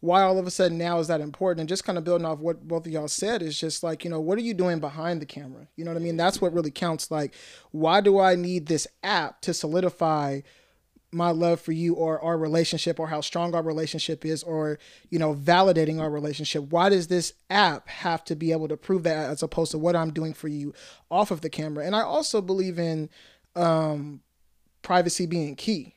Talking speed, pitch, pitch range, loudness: 235 wpm, 165 Hz, 155-175 Hz, -26 LUFS